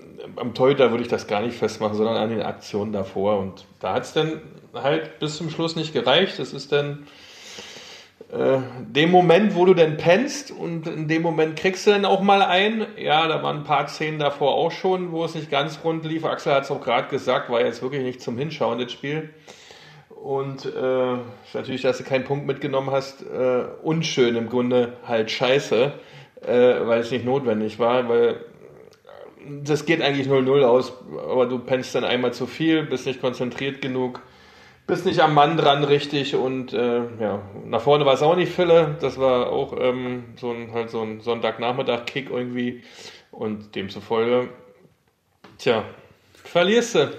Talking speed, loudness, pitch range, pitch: 185 wpm, -22 LUFS, 125-160 Hz, 135 Hz